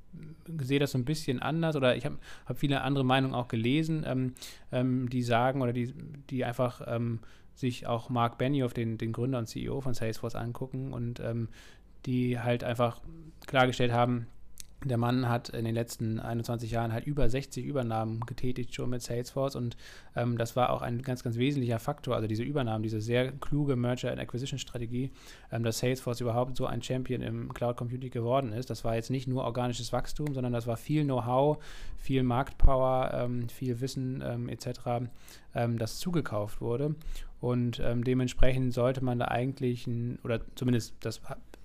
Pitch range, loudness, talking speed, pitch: 120-130 Hz, -32 LUFS, 180 wpm, 125 Hz